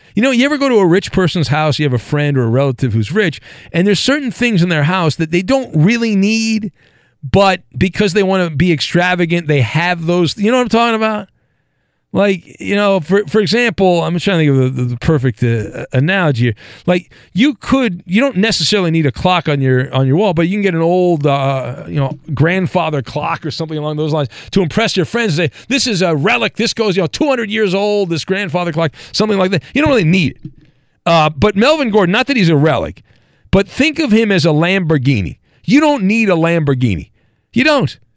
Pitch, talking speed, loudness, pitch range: 175 Hz, 230 wpm, -14 LUFS, 150-210 Hz